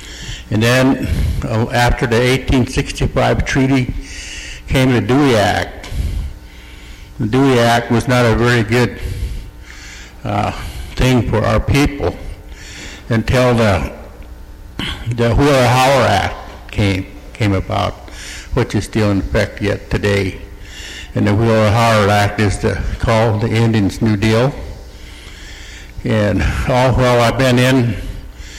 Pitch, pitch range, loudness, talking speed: 105 Hz, 95-120 Hz, -15 LUFS, 120 wpm